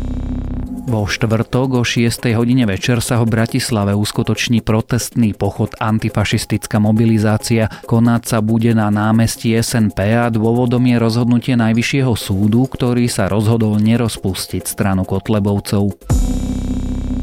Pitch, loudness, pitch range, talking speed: 110 Hz, -16 LUFS, 105-120 Hz, 110 wpm